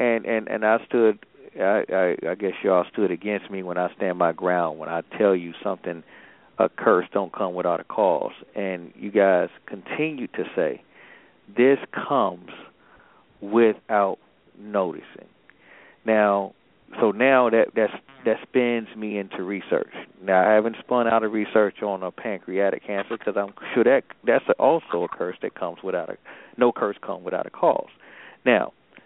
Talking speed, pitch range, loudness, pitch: 165 wpm, 100-115 Hz, -23 LUFS, 105 Hz